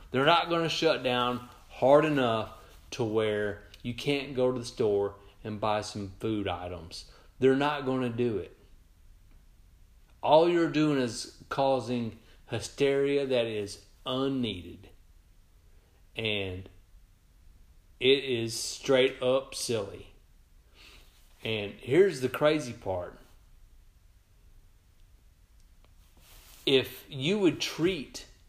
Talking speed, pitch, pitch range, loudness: 105 wpm, 105 Hz, 90-130 Hz, -29 LUFS